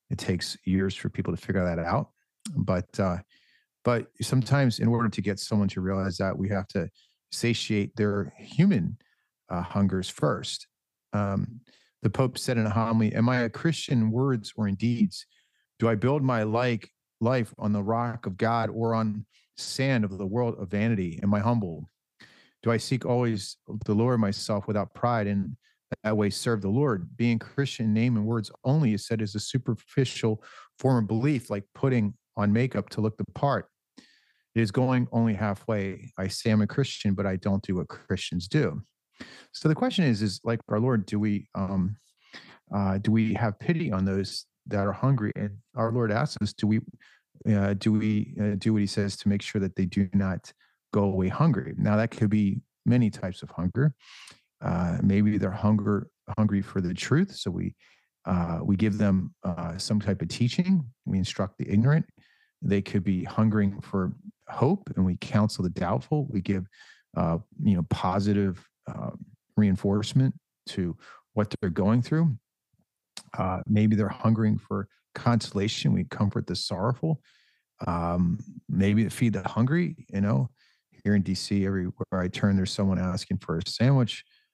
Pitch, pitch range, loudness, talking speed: 105 Hz, 100-120 Hz, -27 LUFS, 180 wpm